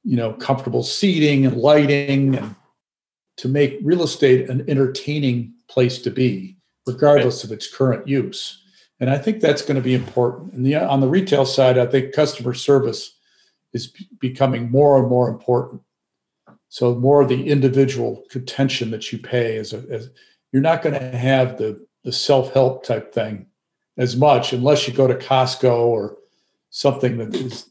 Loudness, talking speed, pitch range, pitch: -18 LUFS, 165 wpm, 125-140 Hz, 130 Hz